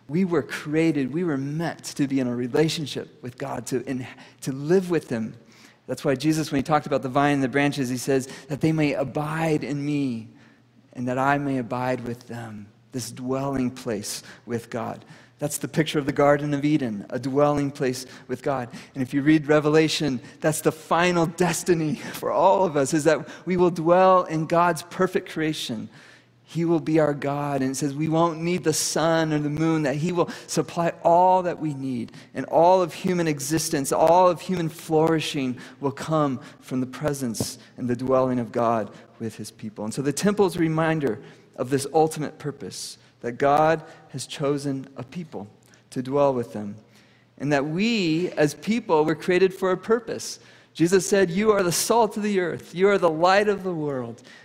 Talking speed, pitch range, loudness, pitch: 195 wpm, 130-165 Hz, -23 LUFS, 150 Hz